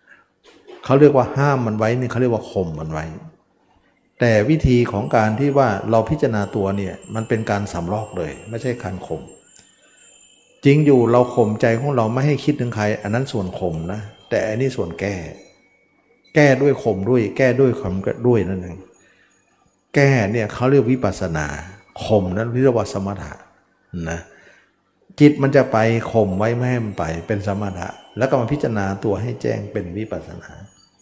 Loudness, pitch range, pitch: -19 LUFS, 95-125 Hz, 110 Hz